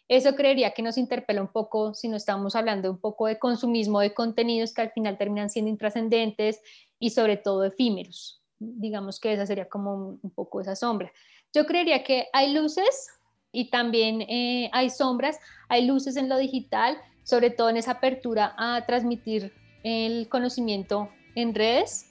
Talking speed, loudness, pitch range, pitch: 170 wpm, -26 LUFS, 215-250 Hz, 230 Hz